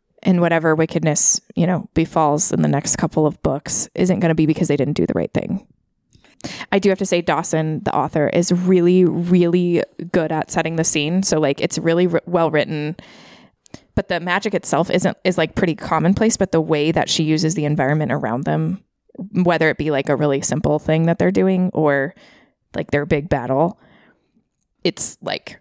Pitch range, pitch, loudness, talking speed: 155-180 Hz, 165 Hz, -18 LUFS, 195 wpm